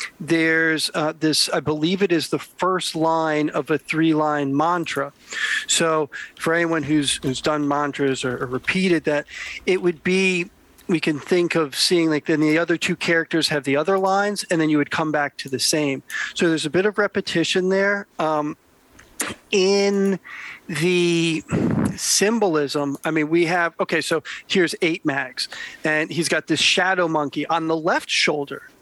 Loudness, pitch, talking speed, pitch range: -21 LUFS, 165 Hz, 170 wpm, 155-185 Hz